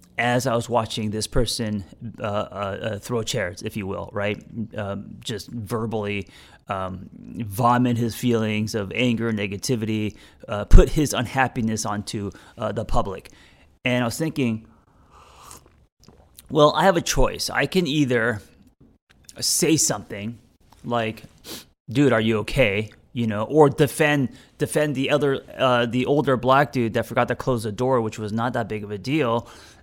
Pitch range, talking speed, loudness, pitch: 110-130 Hz, 155 wpm, -23 LUFS, 120 Hz